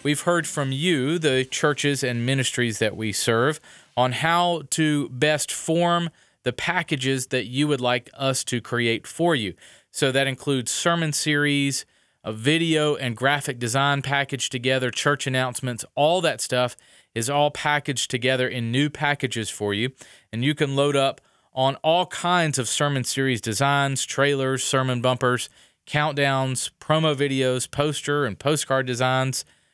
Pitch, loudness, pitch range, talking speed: 135 Hz, -23 LUFS, 125-145 Hz, 150 wpm